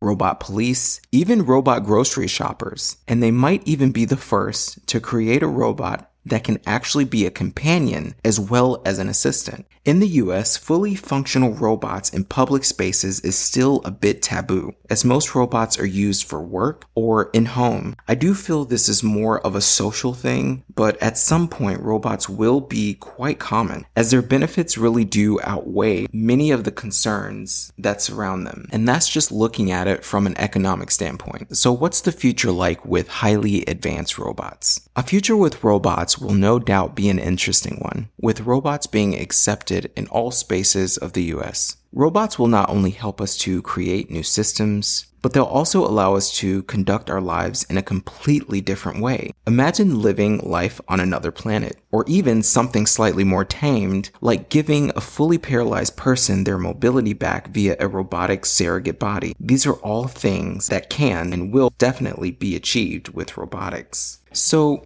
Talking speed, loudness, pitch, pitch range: 175 wpm, -19 LUFS, 110 Hz, 95-130 Hz